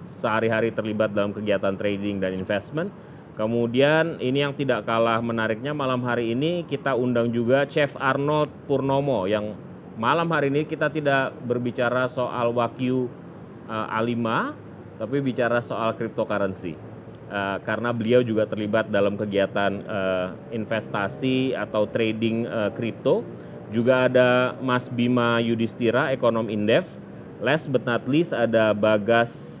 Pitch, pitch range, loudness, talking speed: 115 Hz, 110-130 Hz, -24 LUFS, 130 wpm